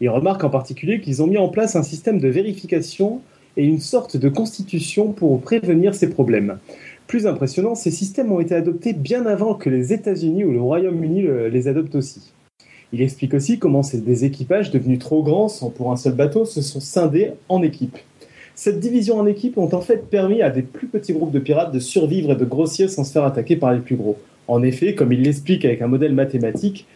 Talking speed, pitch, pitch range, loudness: 215 wpm, 160 Hz, 135-200 Hz, -19 LUFS